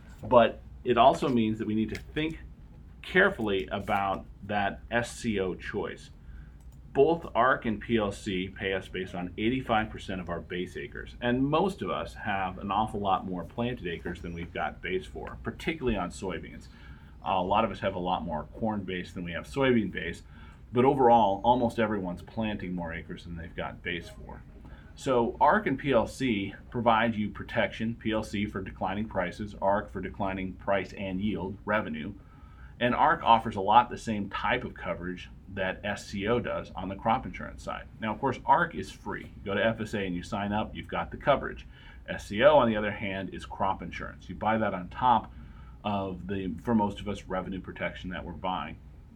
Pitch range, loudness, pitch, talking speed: 90-110 Hz, -29 LUFS, 100 Hz, 185 wpm